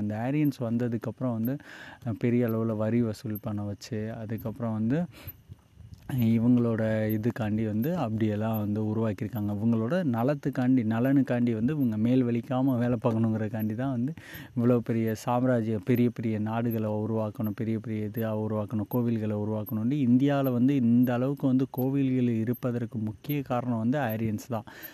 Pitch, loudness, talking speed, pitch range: 115 Hz, -28 LUFS, 125 wpm, 110-125 Hz